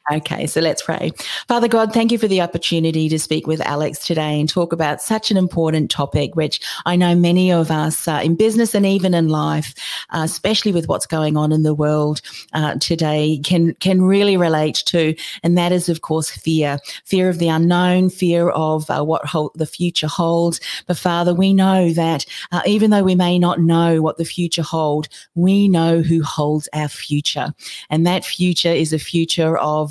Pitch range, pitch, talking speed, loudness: 155-180 Hz, 165 Hz, 195 wpm, -17 LUFS